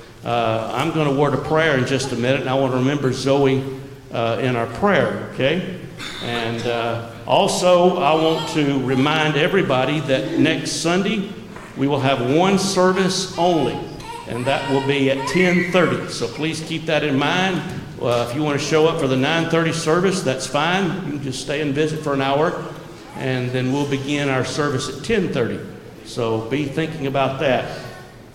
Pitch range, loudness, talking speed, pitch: 130-160 Hz, -19 LUFS, 180 wpm, 140 Hz